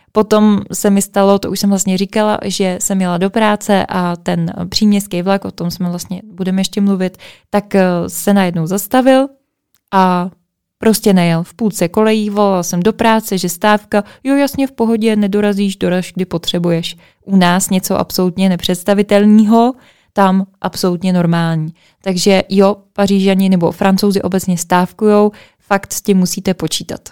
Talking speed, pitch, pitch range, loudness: 155 wpm, 195 Hz, 180-210 Hz, -14 LUFS